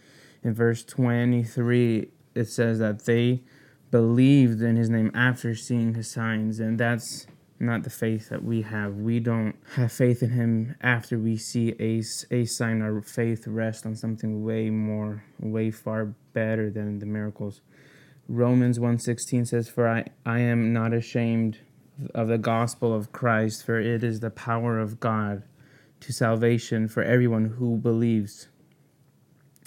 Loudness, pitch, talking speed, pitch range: -26 LUFS, 115 Hz, 150 wpm, 110-120 Hz